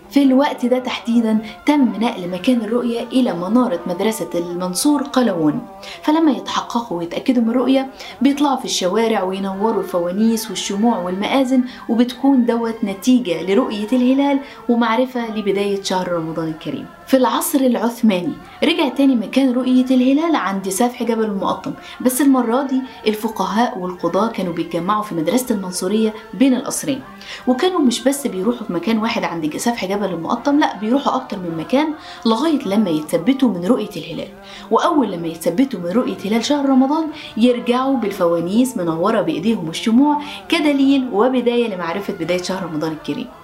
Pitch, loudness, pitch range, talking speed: 235 Hz, -18 LUFS, 195-260 Hz, 140 wpm